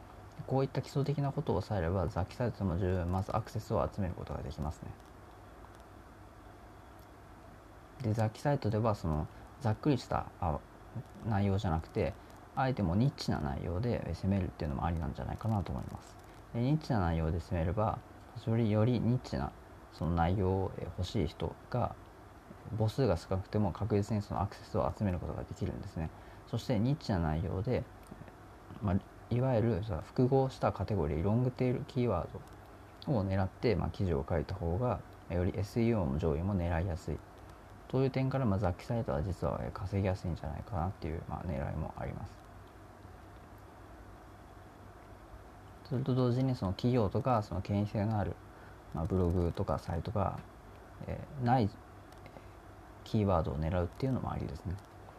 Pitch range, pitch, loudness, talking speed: 90-110 Hz, 100 Hz, -34 LUFS, 340 characters per minute